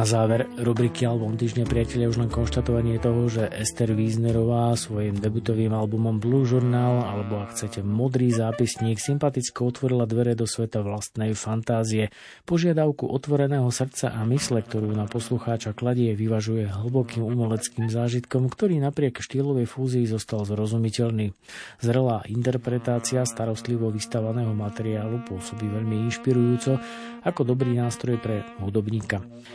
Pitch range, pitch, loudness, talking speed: 110-125 Hz, 115 Hz, -25 LUFS, 125 wpm